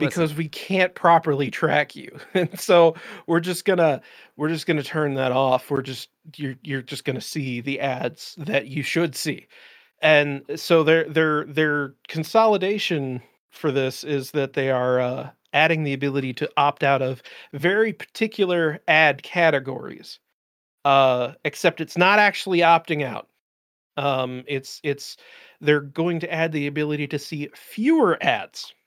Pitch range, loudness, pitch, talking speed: 140-165 Hz, -22 LUFS, 150 Hz, 150 wpm